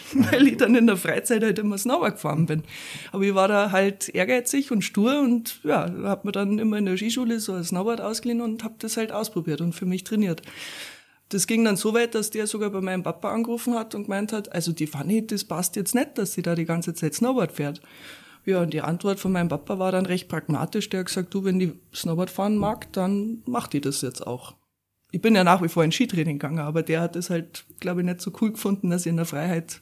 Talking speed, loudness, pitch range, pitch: 250 wpm, -24 LUFS, 170-220 Hz, 195 Hz